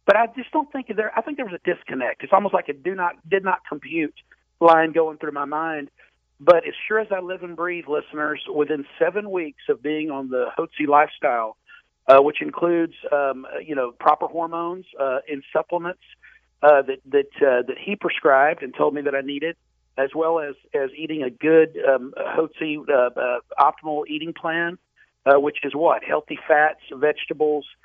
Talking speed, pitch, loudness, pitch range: 190 wpm, 160 Hz, -22 LUFS, 145-175 Hz